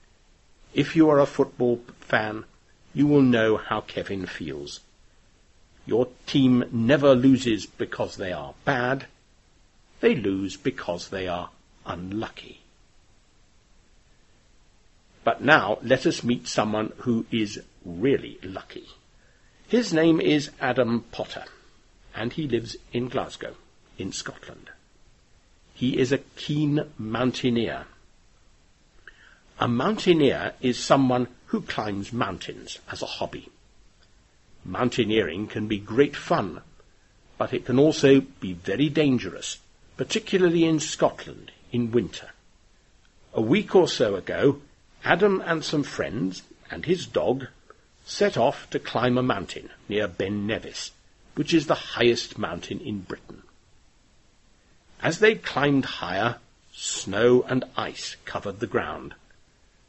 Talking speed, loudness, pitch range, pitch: 120 wpm, -25 LUFS, 105-140 Hz, 120 Hz